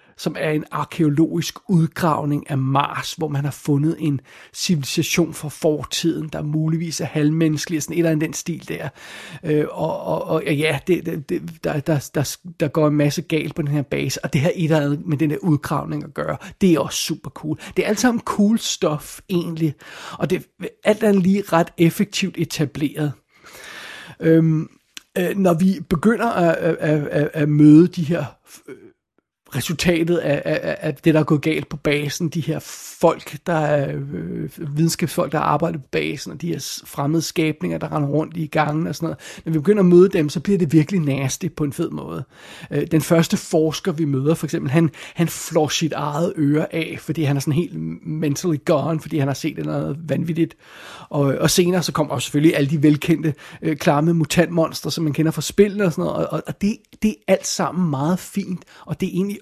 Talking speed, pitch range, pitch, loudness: 205 wpm, 150-170 Hz, 160 Hz, -20 LUFS